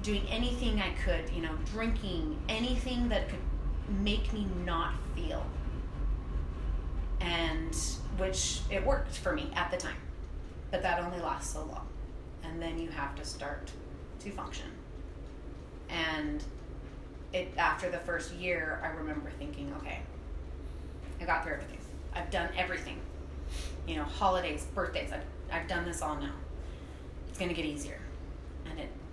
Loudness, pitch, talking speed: -36 LUFS, 70 Hz, 145 wpm